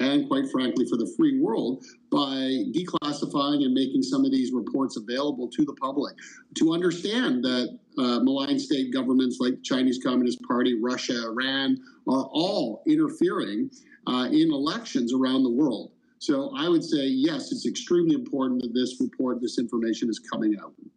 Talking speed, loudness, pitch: 165 wpm, -26 LUFS, 275 Hz